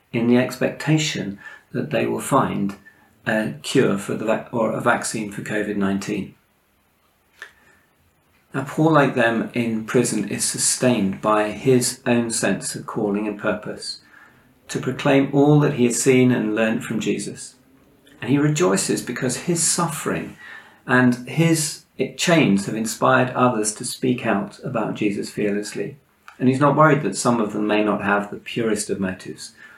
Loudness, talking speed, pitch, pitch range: -20 LUFS, 155 wpm, 125 Hz, 105-135 Hz